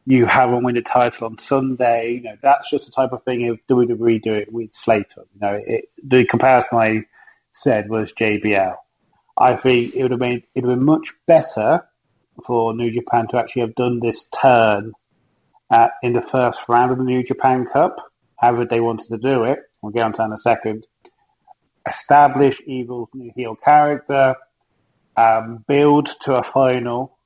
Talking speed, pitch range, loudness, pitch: 190 wpm, 115-130 Hz, -17 LUFS, 120 Hz